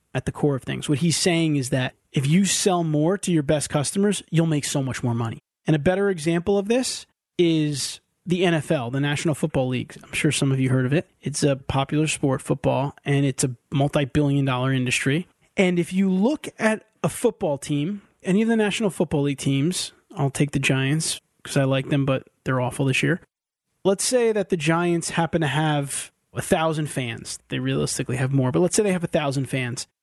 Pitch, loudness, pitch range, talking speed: 150 Hz, -23 LUFS, 135-180 Hz, 215 wpm